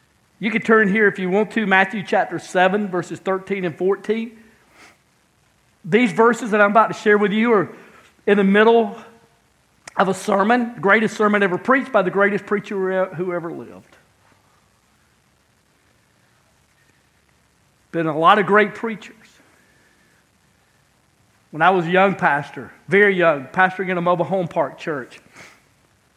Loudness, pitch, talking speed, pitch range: -18 LUFS, 200 Hz, 145 wpm, 180-215 Hz